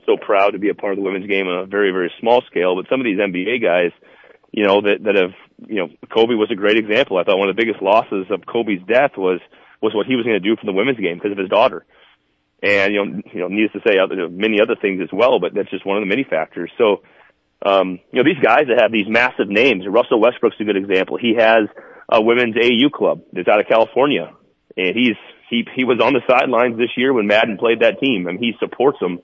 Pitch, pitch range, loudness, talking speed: 105 Hz, 95-115 Hz, -17 LUFS, 260 wpm